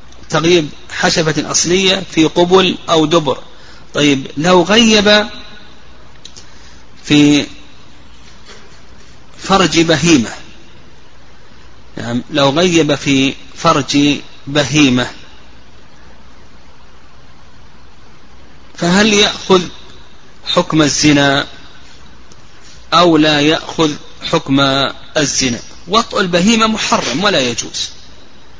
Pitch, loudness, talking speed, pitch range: 155 Hz, -12 LUFS, 70 wpm, 135-175 Hz